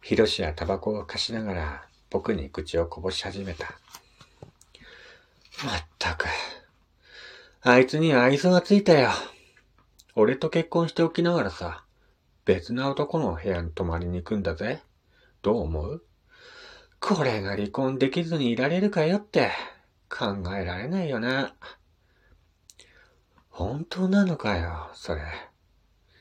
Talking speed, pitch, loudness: 240 characters per minute, 105 Hz, -26 LUFS